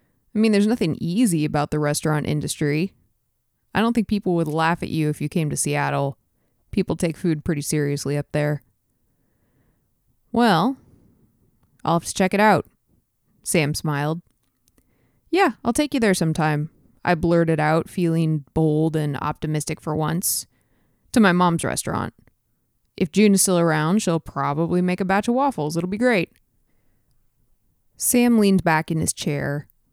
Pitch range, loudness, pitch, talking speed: 145-190 Hz, -21 LUFS, 160 Hz, 155 wpm